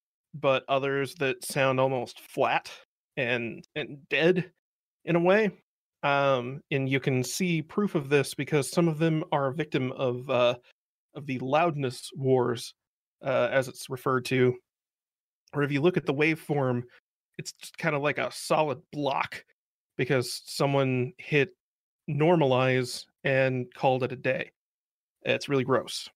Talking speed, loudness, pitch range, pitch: 150 wpm, -27 LUFS, 130-155 Hz, 135 Hz